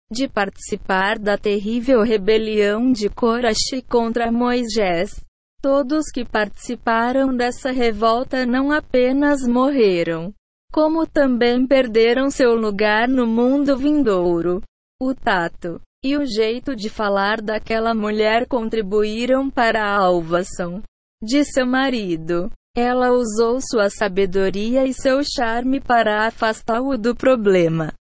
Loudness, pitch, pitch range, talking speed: -19 LUFS, 230 Hz, 210-260 Hz, 115 wpm